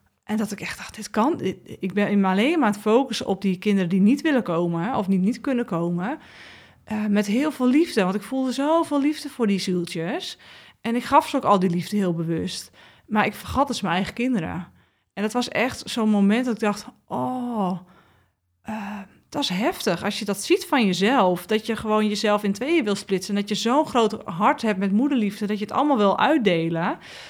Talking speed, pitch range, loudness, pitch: 215 wpm, 195-250 Hz, -23 LUFS, 210 Hz